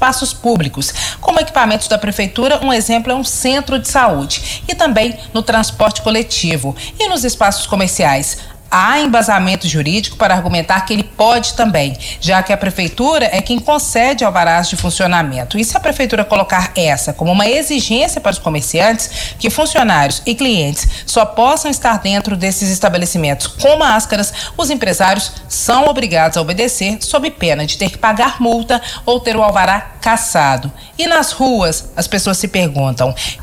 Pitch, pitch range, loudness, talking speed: 215 Hz, 180-245 Hz, -13 LUFS, 160 wpm